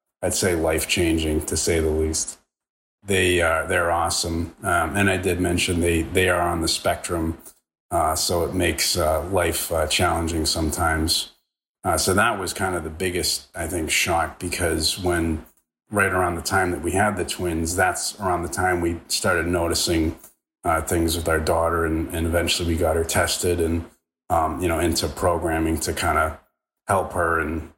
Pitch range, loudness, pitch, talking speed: 80-90 Hz, -22 LUFS, 85 Hz, 180 wpm